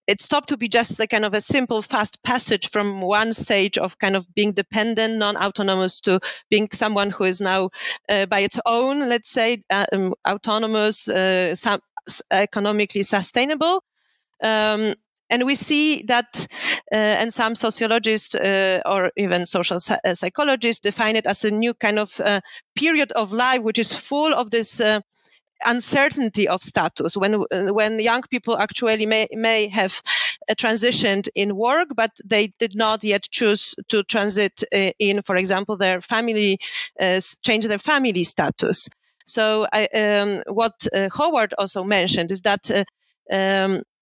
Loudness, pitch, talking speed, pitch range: -20 LUFS, 215 Hz, 160 wpm, 200-230 Hz